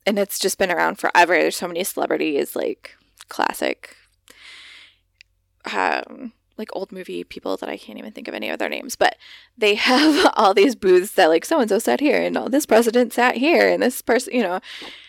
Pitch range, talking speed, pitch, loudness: 185-250 Hz, 200 wpm, 210 Hz, -19 LUFS